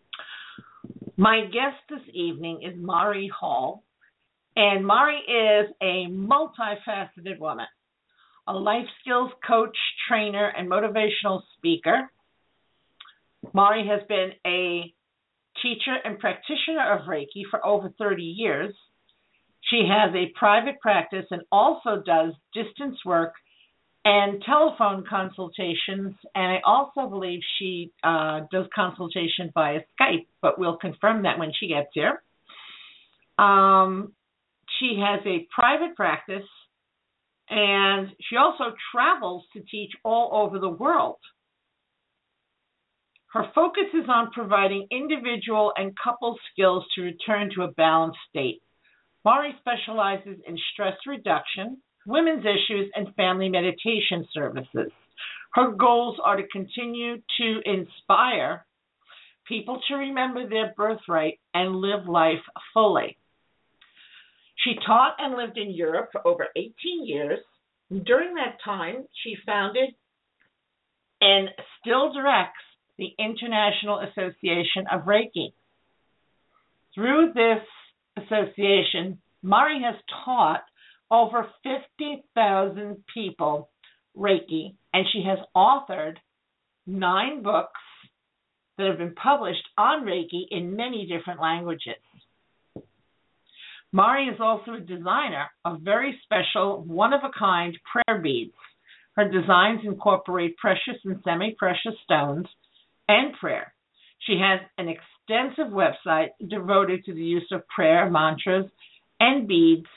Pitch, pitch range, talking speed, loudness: 205 Hz, 185-235 Hz, 110 wpm, -24 LUFS